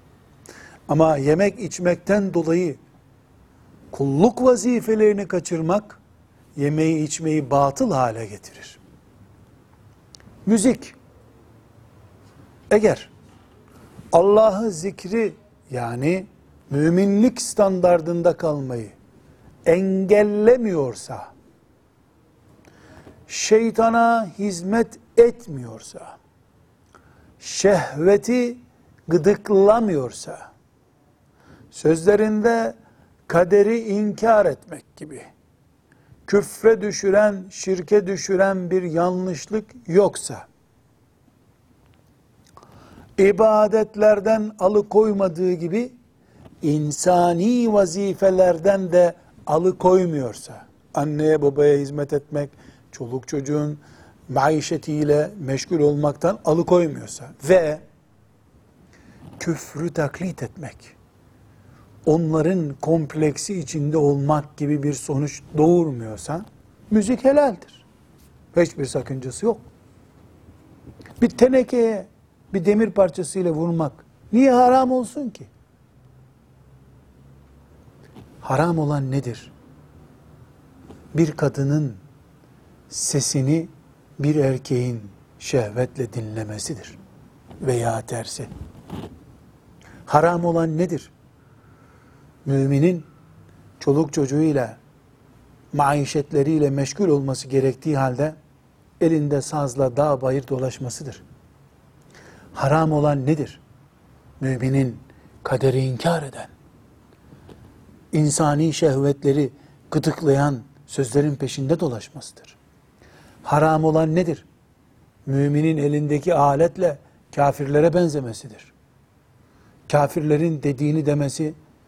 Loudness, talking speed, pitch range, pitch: -20 LUFS, 65 wpm, 135-185 Hz, 150 Hz